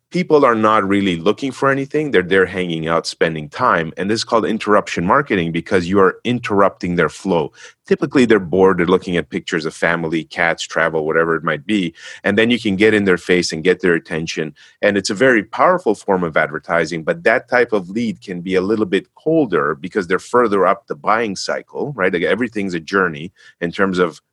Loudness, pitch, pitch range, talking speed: -17 LUFS, 100 Hz, 90-115 Hz, 210 wpm